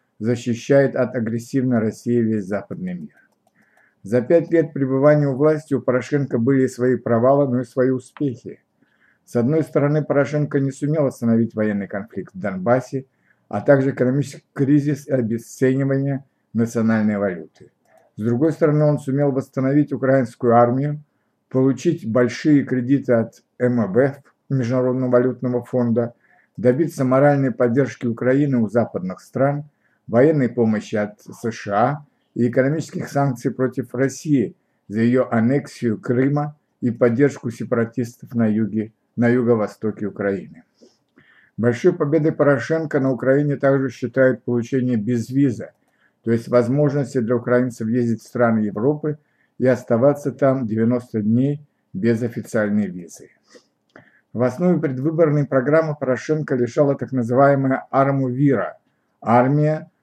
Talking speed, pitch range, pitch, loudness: 125 wpm, 120-140 Hz, 130 Hz, -20 LUFS